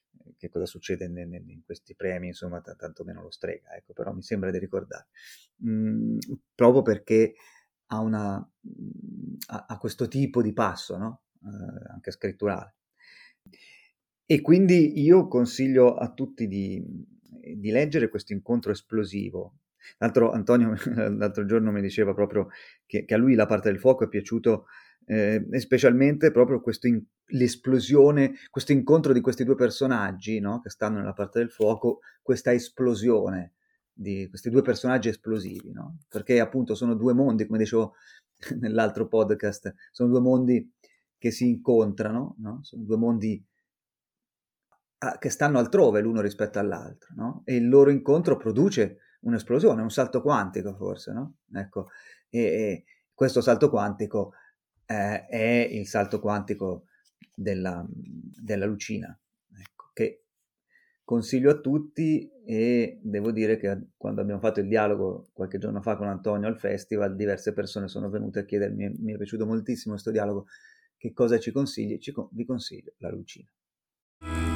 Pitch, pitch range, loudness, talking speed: 115 Hz, 105-130 Hz, -25 LUFS, 150 wpm